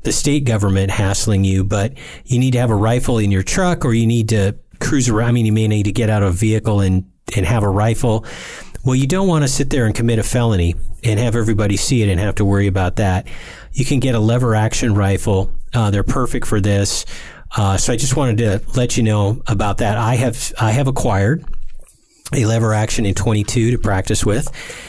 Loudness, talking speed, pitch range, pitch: -17 LUFS, 230 wpm, 100-125 Hz, 110 Hz